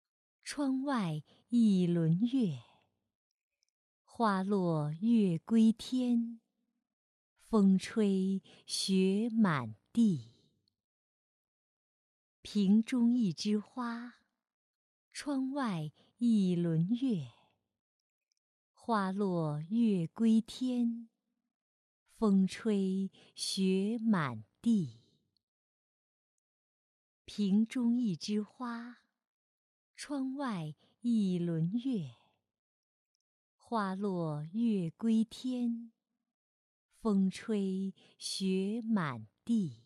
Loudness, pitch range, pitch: -33 LUFS, 170-235 Hz, 210 Hz